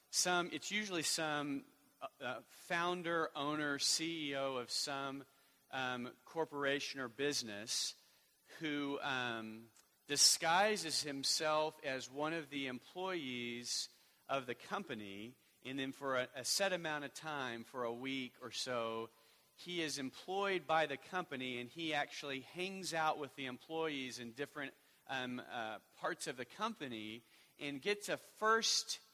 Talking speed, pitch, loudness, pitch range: 135 wpm, 140 Hz, -39 LUFS, 125-160 Hz